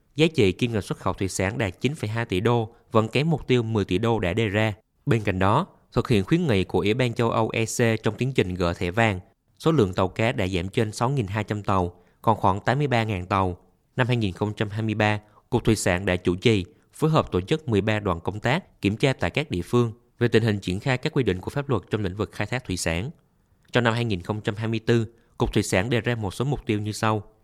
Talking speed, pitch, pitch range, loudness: 235 wpm, 110 Hz, 100-120 Hz, -24 LUFS